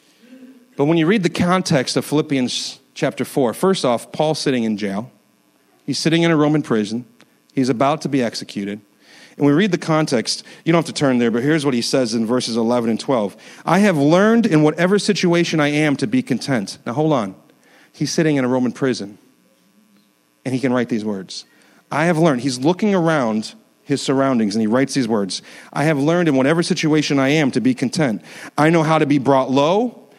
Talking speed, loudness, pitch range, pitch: 210 wpm, -18 LUFS, 125-165 Hz, 145 Hz